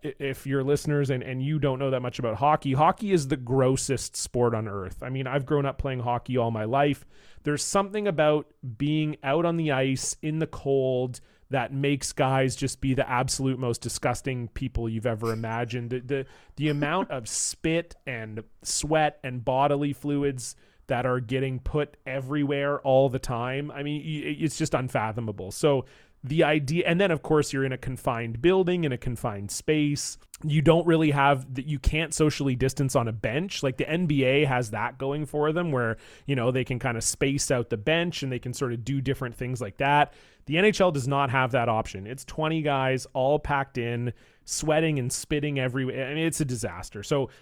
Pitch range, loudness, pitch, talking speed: 125-150 Hz, -27 LUFS, 135 Hz, 200 wpm